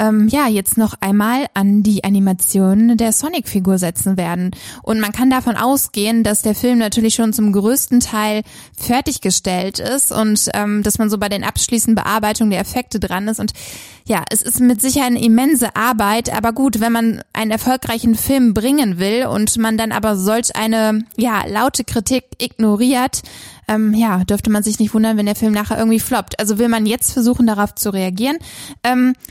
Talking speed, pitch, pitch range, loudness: 180 wpm, 220 Hz, 210-240 Hz, -15 LUFS